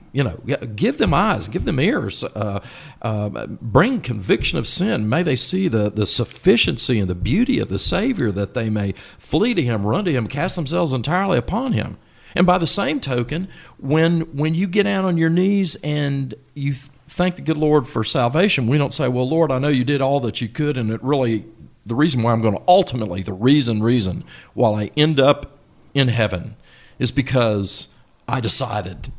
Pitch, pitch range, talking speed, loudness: 135 Hz, 115-160 Hz, 200 wpm, -19 LUFS